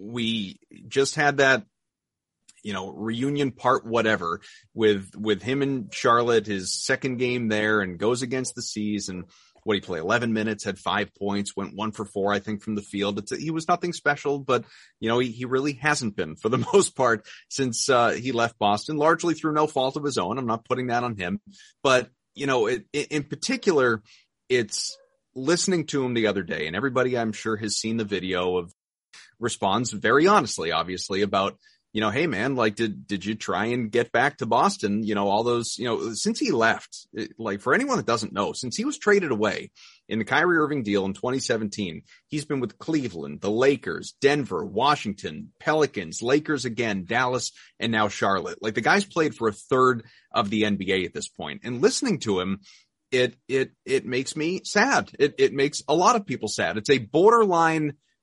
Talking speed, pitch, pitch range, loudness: 200 wpm, 120 Hz, 105-145 Hz, -24 LUFS